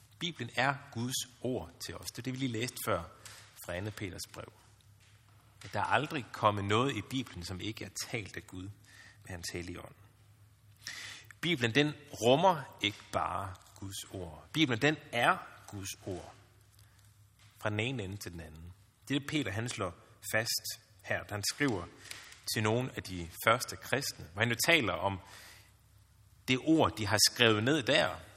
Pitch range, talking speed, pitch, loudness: 100-120 Hz, 175 wpm, 105 Hz, -33 LUFS